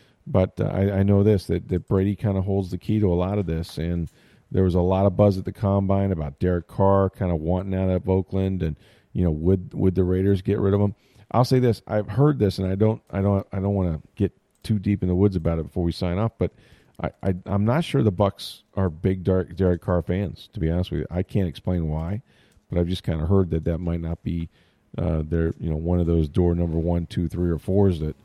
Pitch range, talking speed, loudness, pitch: 85-100 Hz, 265 wpm, -24 LUFS, 95 Hz